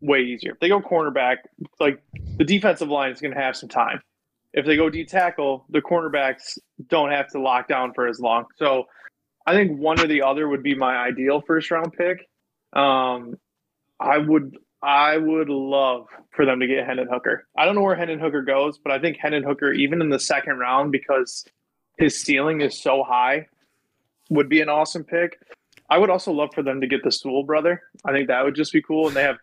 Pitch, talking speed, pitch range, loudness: 145 Hz, 215 wpm, 135-160 Hz, -21 LUFS